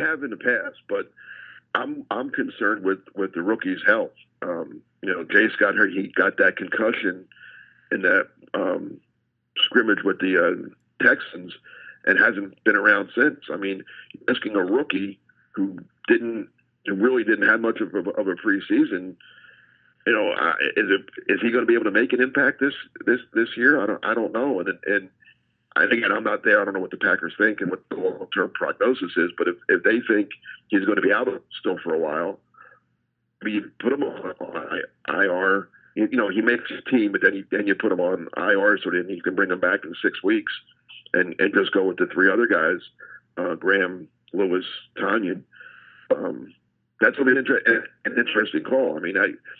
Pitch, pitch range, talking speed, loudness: 375 Hz, 315-470 Hz, 200 wpm, -22 LUFS